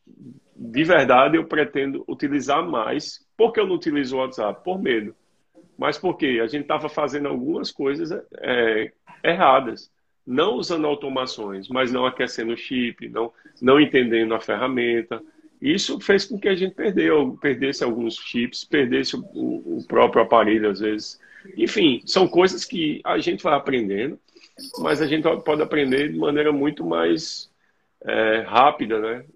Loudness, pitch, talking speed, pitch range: -21 LUFS, 145 Hz, 150 wpm, 120-195 Hz